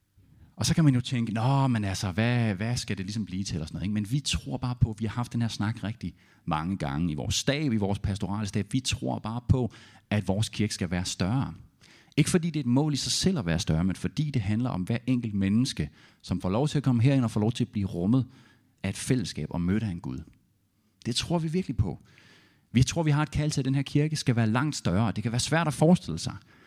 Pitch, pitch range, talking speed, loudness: 110 Hz, 100-130 Hz, 270 wpm, -28 LUFS